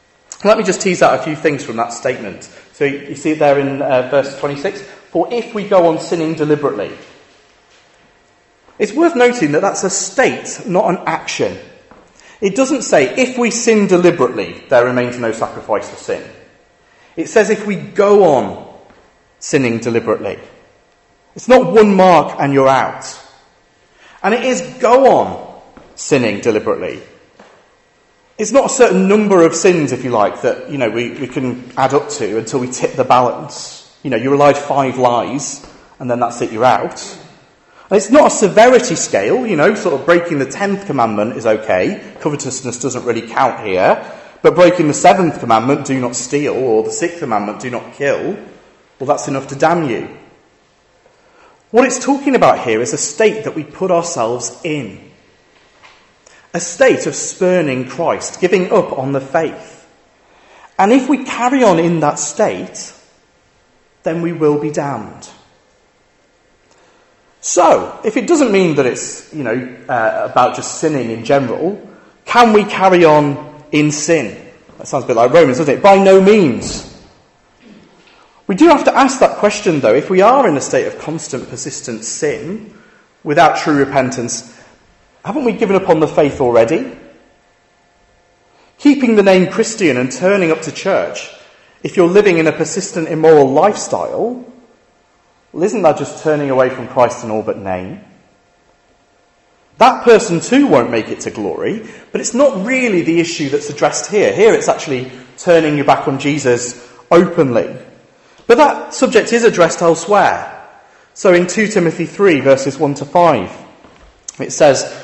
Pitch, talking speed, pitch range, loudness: 170 Hz, 165 wpm, 140-215 Hz, -13 LUFS